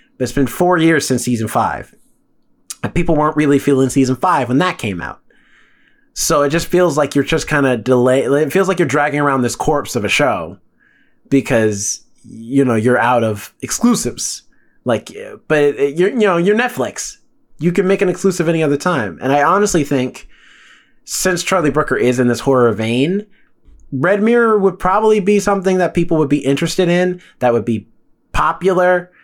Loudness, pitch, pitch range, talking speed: -15 LUFS, 155 Hz, 130-185 Hz, 185 wpm